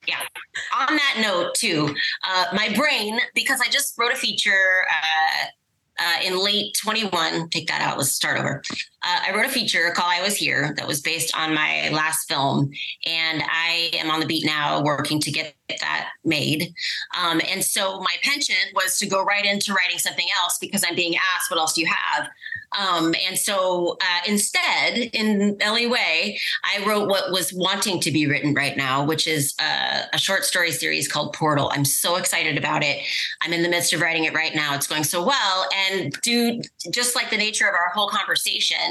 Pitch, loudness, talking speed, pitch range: 180 Hz, -21 LUFS, 200 wpm, 160-205 Hz